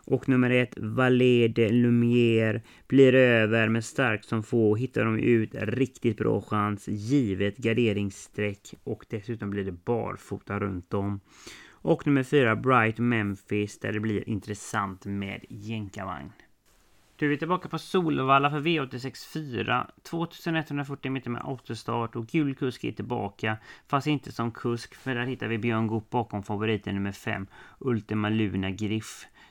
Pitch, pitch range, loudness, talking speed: 115 Hz, 105-130 Hz, -27 LUFS, 150 wpm